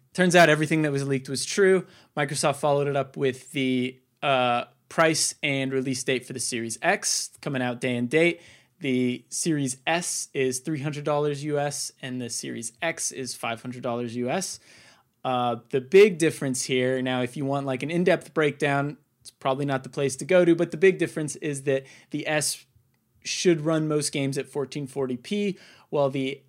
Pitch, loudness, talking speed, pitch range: 140 Hz, -25 LUFS, 175 wpm, 130-155 Hz